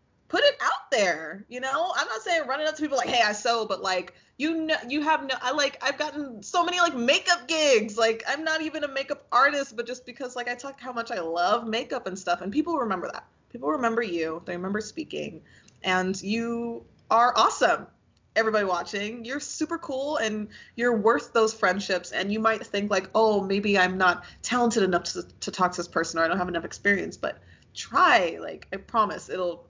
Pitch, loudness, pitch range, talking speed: 230 Hz, -26 LUFS, 195-280 Hz, 215 wpm